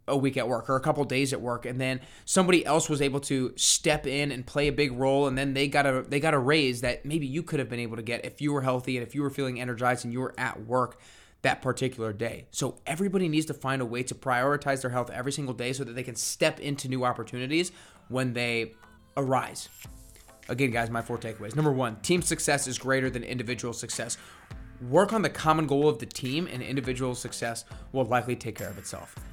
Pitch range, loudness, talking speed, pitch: 125-145 Hz, -28 LUFS, 240 wpm, 130 Hz